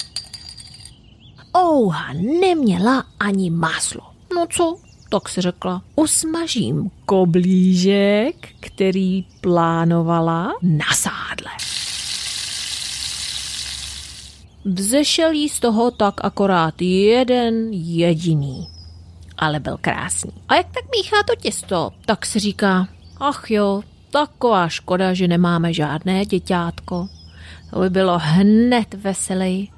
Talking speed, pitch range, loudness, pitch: 95 wpm, 170-230 Hz, -19 LUFS, 190 Hz